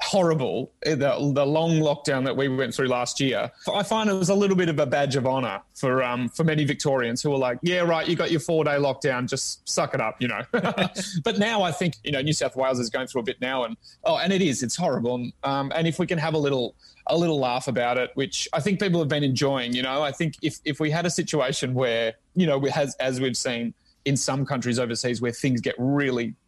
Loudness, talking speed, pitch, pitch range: -24 LUFS, 245 wpm, 140 Hz, 130-165 Hz